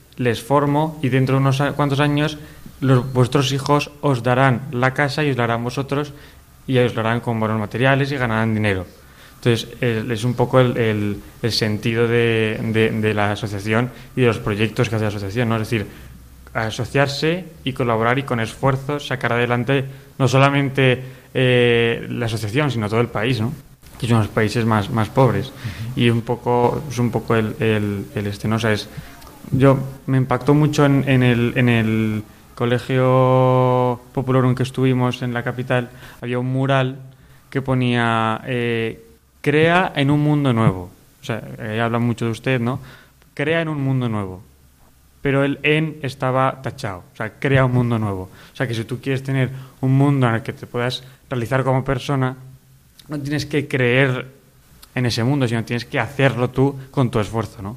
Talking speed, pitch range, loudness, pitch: 185 wpm, 115-135 Hz, -19 LUFS, 125 Hz